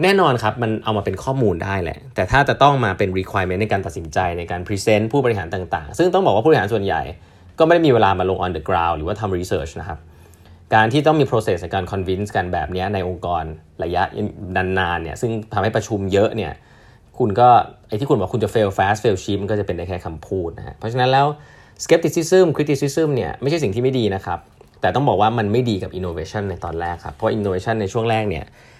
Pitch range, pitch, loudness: 90-120 Hz, 105 Hz, -19 LUFS